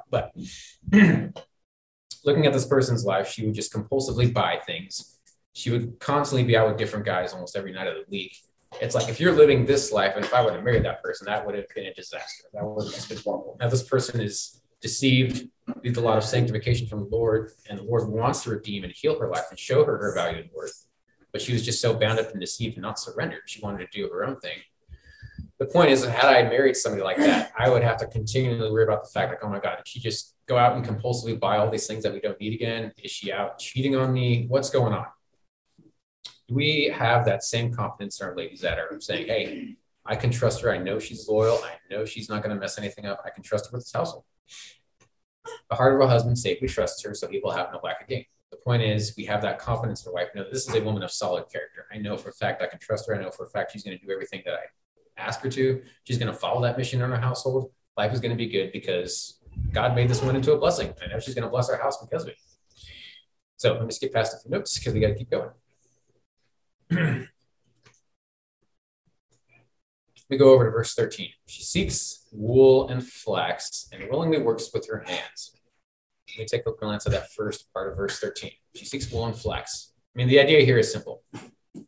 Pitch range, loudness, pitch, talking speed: 110-135 Hz, -25 LUFS, 120 Hz, 245 wpm